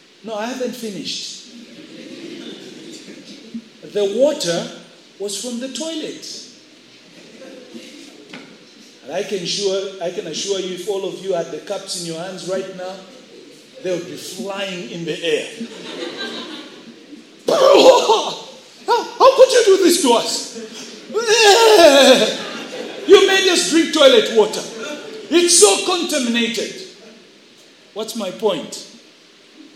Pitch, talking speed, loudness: 255 Hz, 115 wpm, -16 LUFS